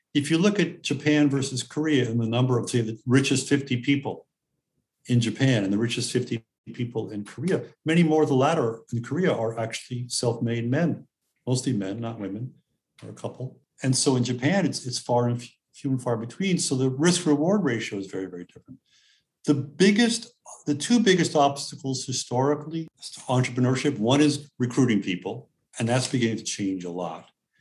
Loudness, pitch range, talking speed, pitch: -25 LUFS, 115-145 Hz, 185 wpm, 130 Hz